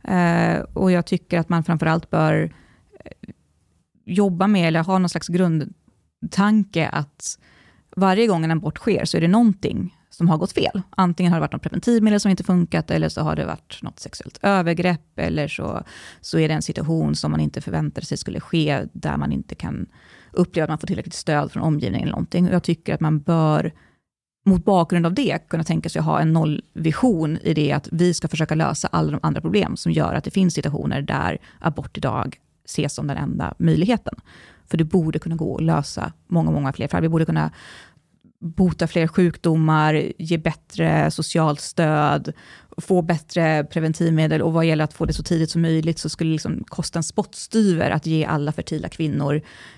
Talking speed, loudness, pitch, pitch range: 195 wpm, -21 LUFS, 165 Hz, 155-180 Hz